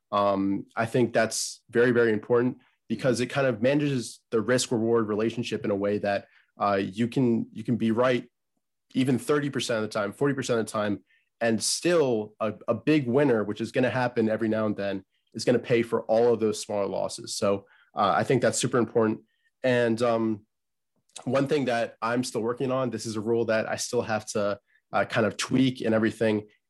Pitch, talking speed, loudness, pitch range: 115 Hz, 205 wpm, -26 LUFS, 110-125 Hz